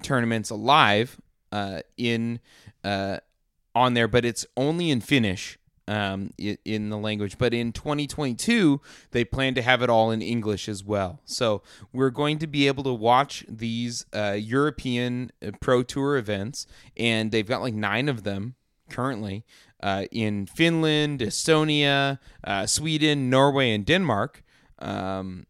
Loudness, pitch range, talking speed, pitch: -24 LUFS, 105-140 Hz, 145 wpm, 120 Hz